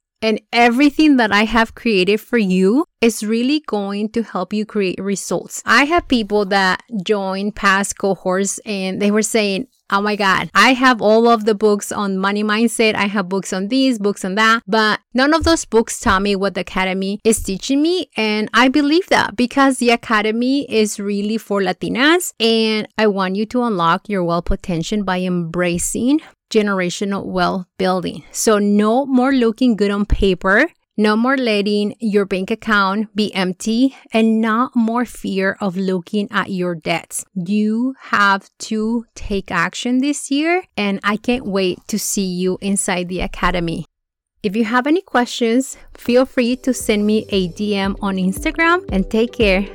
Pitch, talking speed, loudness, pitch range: 210 Hz, 170 wpm, -17 LUFS, 195-235 Hz